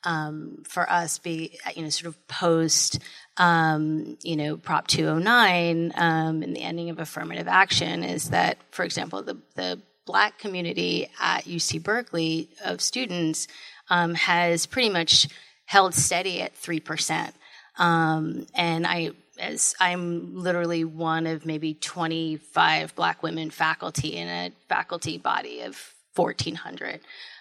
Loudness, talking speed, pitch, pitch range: -25 LUFS, 145 wpm, 165 Hz, 155-175 Hz